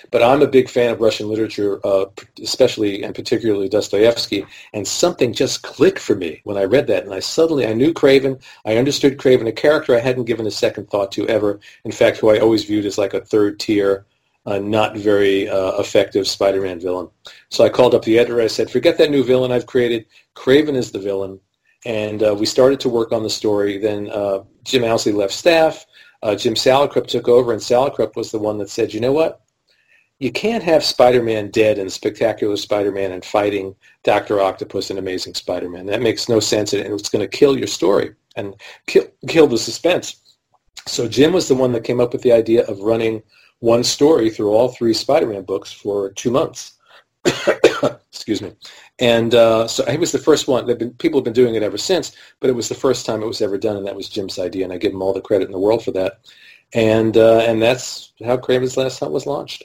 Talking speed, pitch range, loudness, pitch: 215 wpm, 105-125 Hz, -17 LUFS, 115 Hz